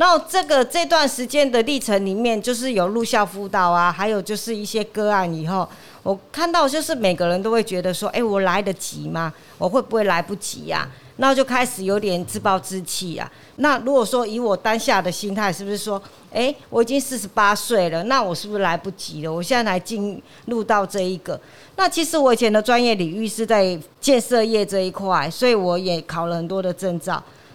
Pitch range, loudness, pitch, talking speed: 185-240 Hz, -20 LUFS, 205 Hz, 310 characters per minute